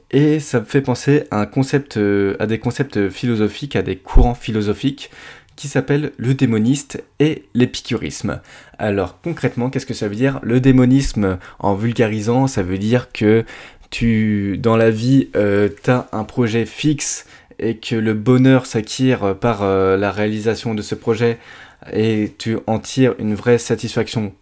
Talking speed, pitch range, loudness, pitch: 160 wpm, 105-130 Hz, -18 LUFS, 115 Hz